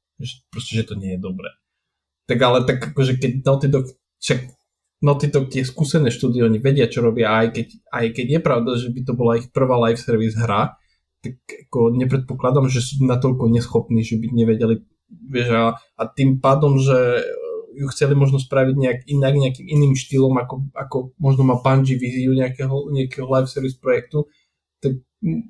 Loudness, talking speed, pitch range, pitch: -19 LUFS, 175 wpm, 115-135 Hz, 130 Hz